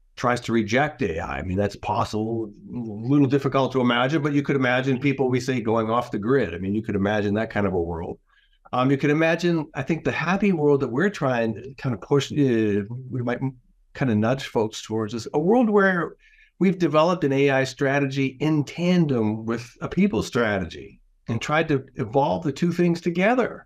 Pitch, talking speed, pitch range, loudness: 135 Hz, 205 wpm, 115-150 Hz, -23 LUFS